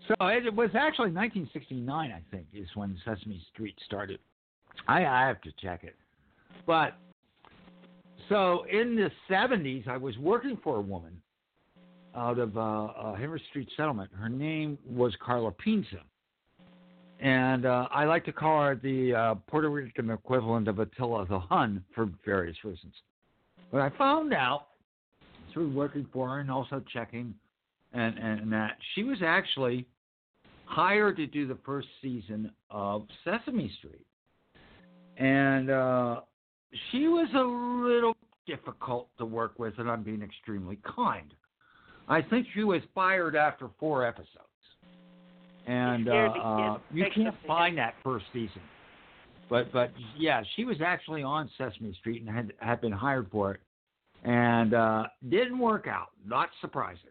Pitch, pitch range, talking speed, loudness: 125 Hz, 110-155 Hz, 150 wpm, -30 LUFS